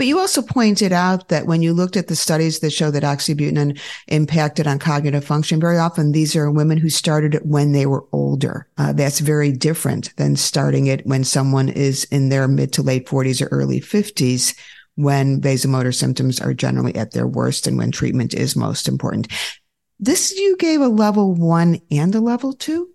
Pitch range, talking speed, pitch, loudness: 135-170 Hz, 195 wpm, 150 Hz, -18 LUFS